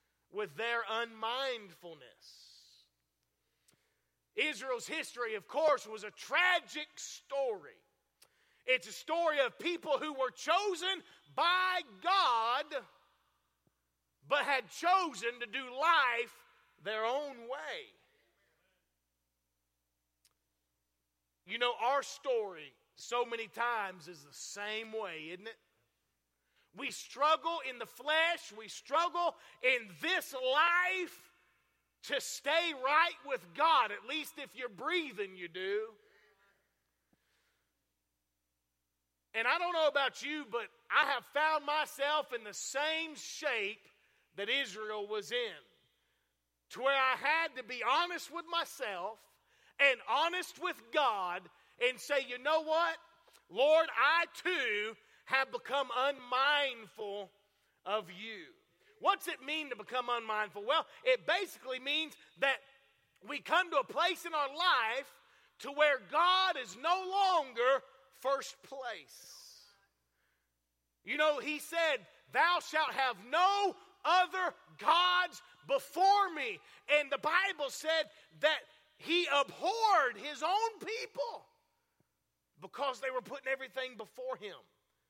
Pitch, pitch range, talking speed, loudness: 280 Hz, 225-340 Hz, 115 wpm, -33 LUFS